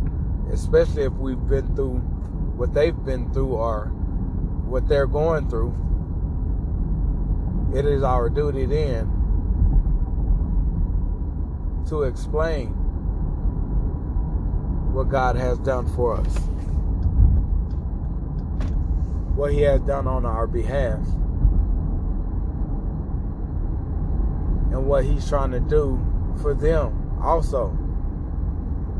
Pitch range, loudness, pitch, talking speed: 75-85 Hz, -24 LUFS, 80 Hz, 90 wpm